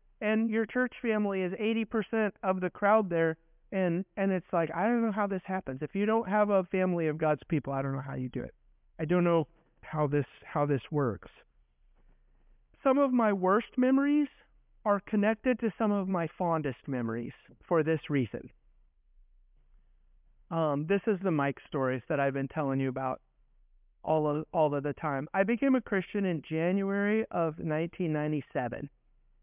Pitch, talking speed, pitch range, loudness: 165 Hz, 175 wpm, 140-205 Hz, -30 LUFS